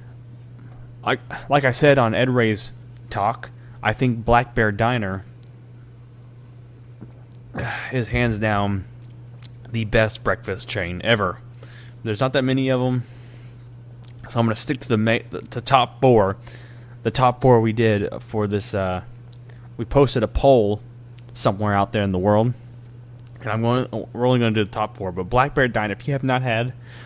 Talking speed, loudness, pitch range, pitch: 165 wpm, -21 LUFS, 110-120 Hz, 120 Hz